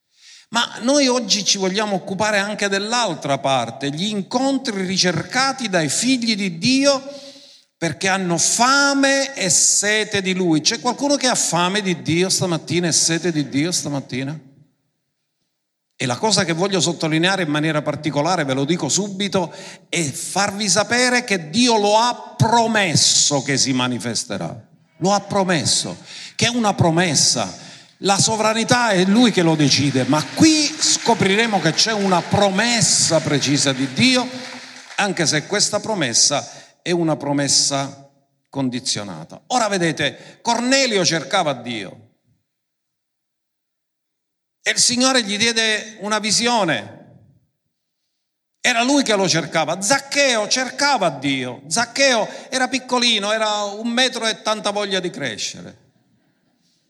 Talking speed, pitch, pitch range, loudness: 130 wpm, 195 Hz, 155-235 Hz, -18 LUFS